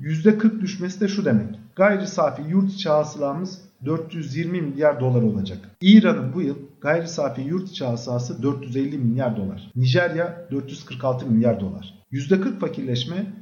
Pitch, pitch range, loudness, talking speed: 145 Hz, 125-180 Hz, -22 LUFS, 130 wpm